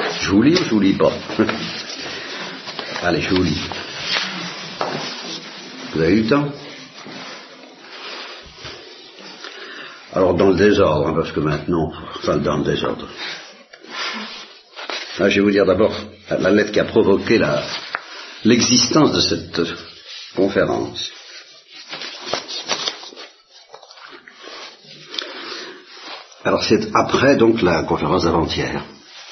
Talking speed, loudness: 105 wpm, -19 LUFS